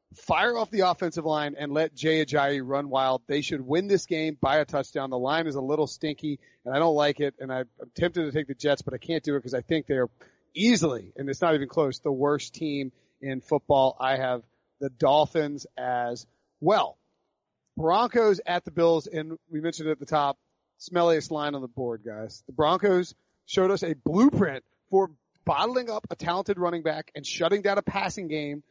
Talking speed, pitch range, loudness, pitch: 205 wpm, 140-170 Hz, -27 LUFS, 155 Hz